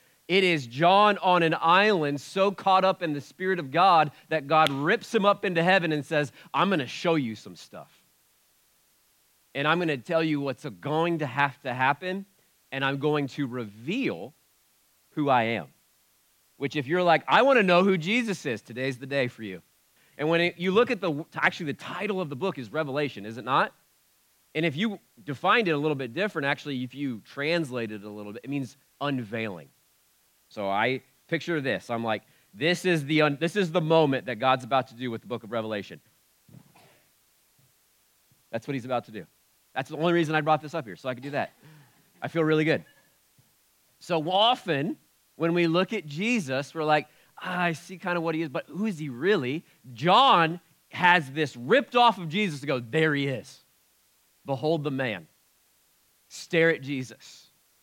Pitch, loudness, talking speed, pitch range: 155 Hz, -26 LUFS, 200 wpm, 130-175 Hz